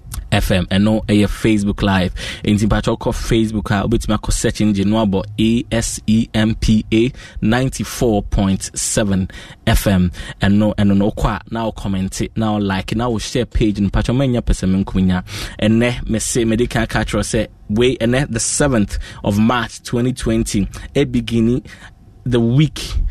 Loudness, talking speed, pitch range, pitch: -17 LUFS, 150 wpm, 100-115 Hz, 110 Hz